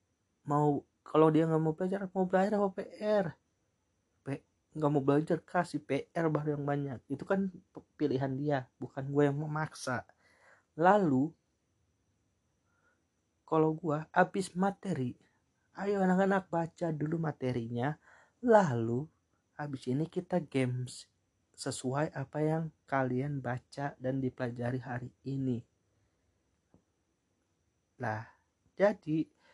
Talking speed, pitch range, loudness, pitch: 105 wpm, 120-160 Hz, -33 LUFS, 140 Hz